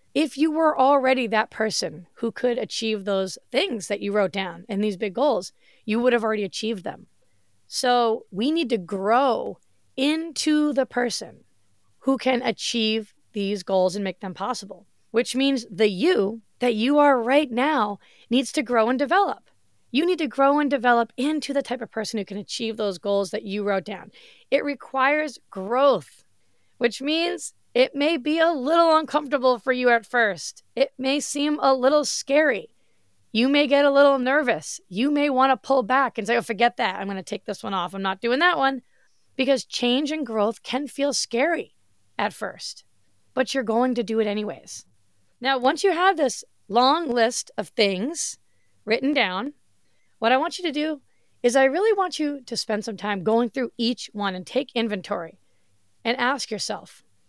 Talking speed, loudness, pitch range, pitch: 185 wpm, -23 LUFS, 210-280 Hz, 245 Hz